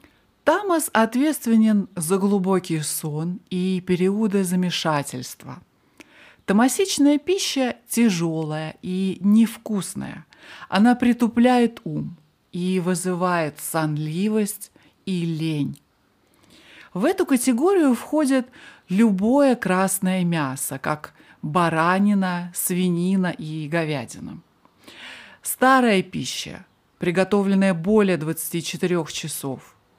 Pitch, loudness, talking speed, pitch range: 185 Hz, -21 LUFS, 80 wpm, 170-230 Hz